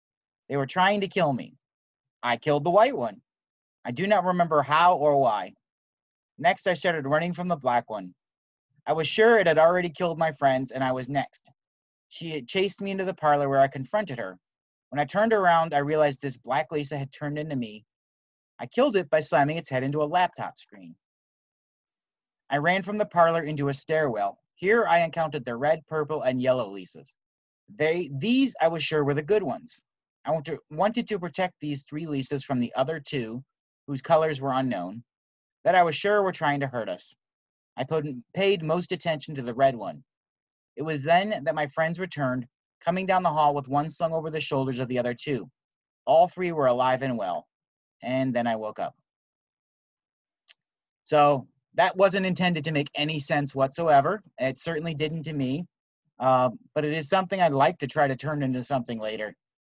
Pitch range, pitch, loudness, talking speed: 135-175 Hz, 150 Hz, -25 LUFS, 195 wpm